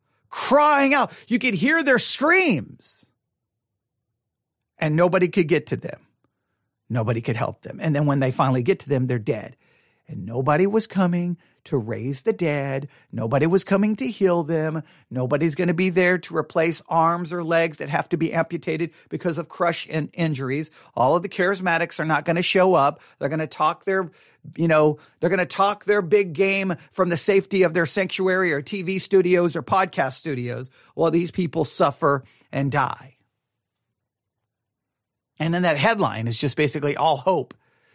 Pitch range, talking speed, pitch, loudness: 135-185 Hz, 175 wpm, 165 Hz, -22 LUFS